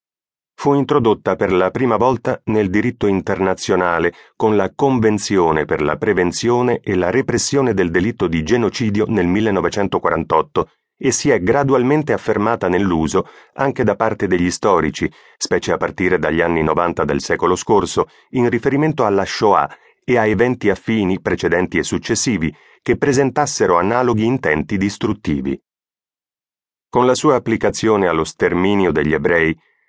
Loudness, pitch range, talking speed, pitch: -17 LUFS, 95-125 Hz, 135 wpm, 110 Hz